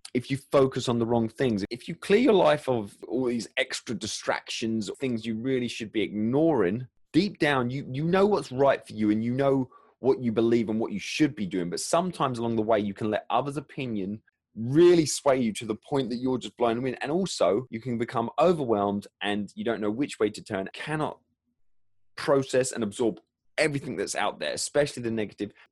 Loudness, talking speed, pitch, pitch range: -27 LUFS, 215 wpm, 120 Hz, 110-140 Hz